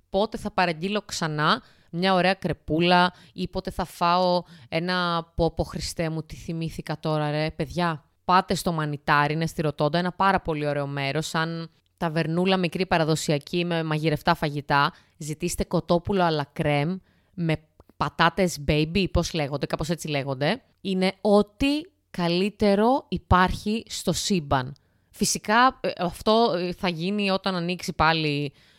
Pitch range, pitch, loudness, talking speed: 155-190 Hz, 175 Hz, -25 LUFS, 130 wpm